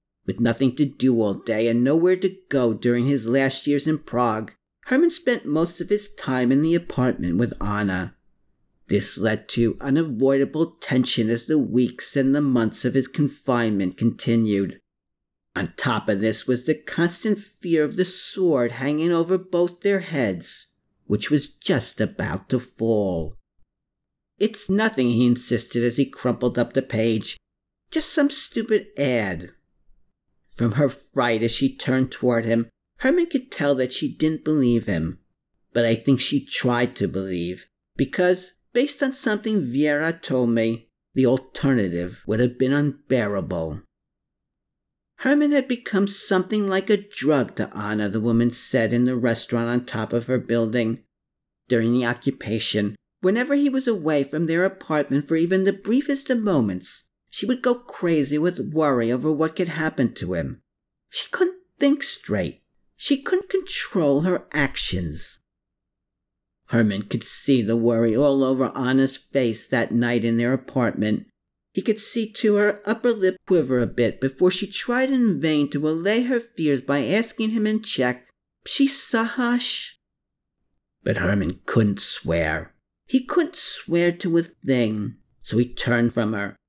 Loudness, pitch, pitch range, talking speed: -22 LUFS, 135 Hz, 115-185 Hz, 155 wpm